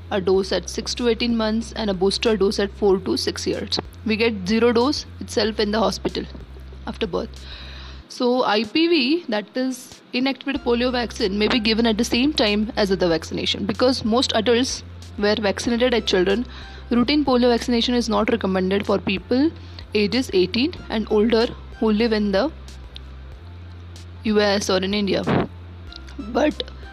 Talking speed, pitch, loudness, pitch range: 160 wpm, 215 Hz, -21 LUFS, 185-240 Hz